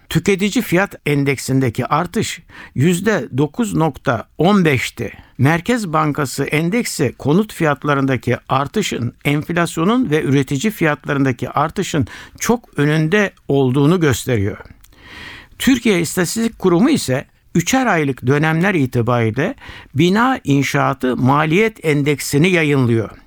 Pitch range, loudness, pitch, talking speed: 130-180 Hz, -17 LUFS, 150 Hz, 85 wpm